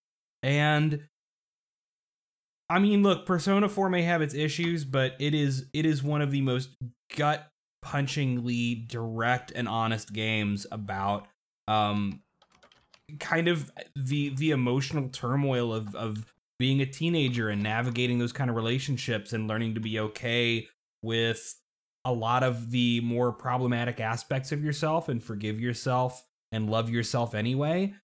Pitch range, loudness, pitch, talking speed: 115-150 Hz, -28 LUFS, 125 Hz, 140 wpm